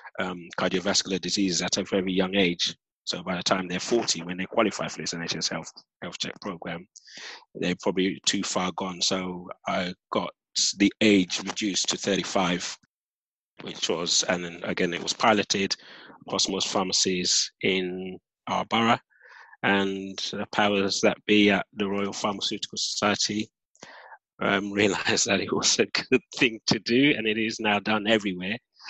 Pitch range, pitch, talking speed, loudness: 90-105 Hz, 95 Hz, 160 wpm, -25 LUFS